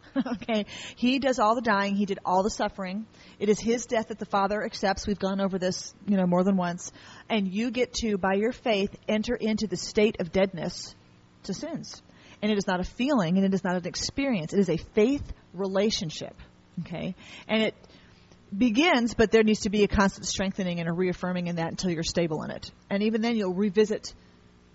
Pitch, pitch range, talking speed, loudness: 200 Hz, 180-220 Hz, 210 wpm, -27 LUFS